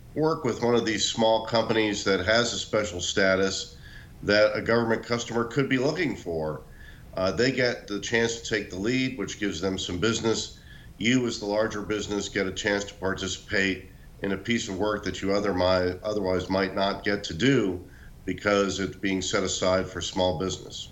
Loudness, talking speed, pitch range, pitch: -26 LUFS, 185 wpm, 95-115 Hz, 100 Hz